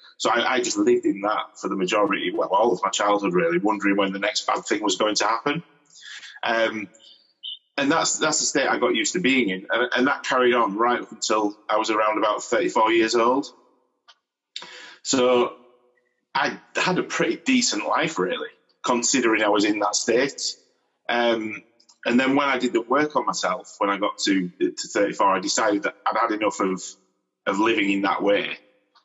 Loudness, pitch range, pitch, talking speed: -22 LUFS, 105-145 Hz, 115 Hz, 195 wpm